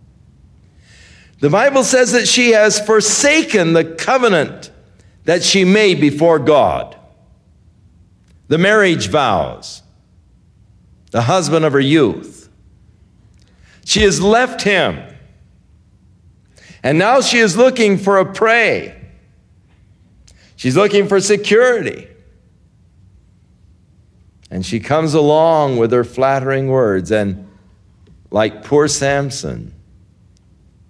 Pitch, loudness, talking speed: 110 Hz, -13 LUFS, 95 wpm